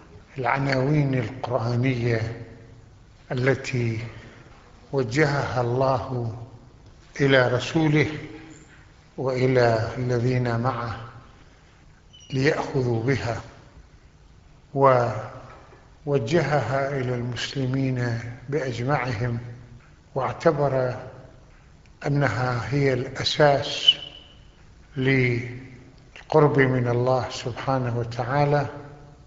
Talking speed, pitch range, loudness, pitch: 50 wpm, 120-140 Hz, -24 LUFS, 130 Hz